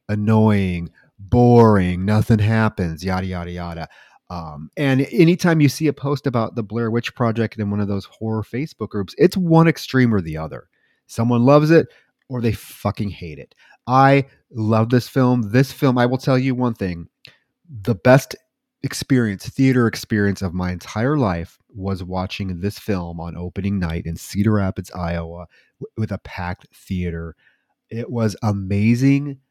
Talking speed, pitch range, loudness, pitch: 165 wpm, 95-130 Hz, -19 LUFS, 110 Hz